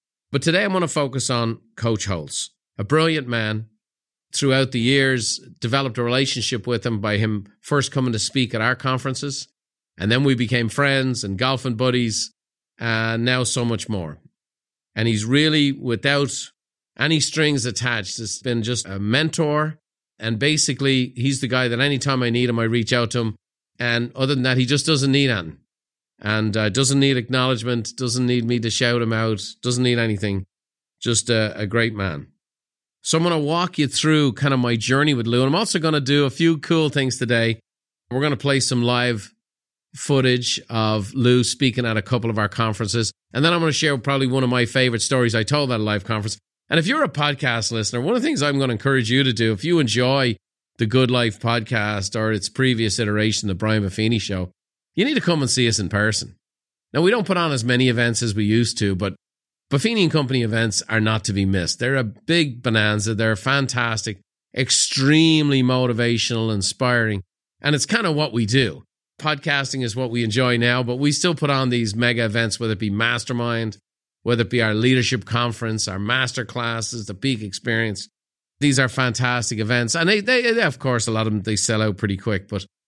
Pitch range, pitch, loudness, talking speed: 110-135 Hz, 120 Hz, -20 LUFS, 205 wpm